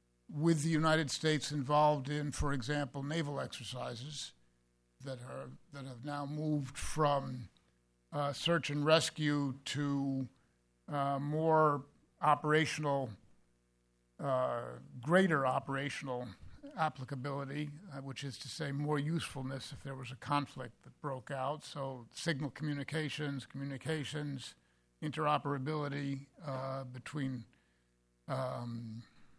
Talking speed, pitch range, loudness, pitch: 105 wpm, 125-150 Hz, -36 LUFS, 140 Hz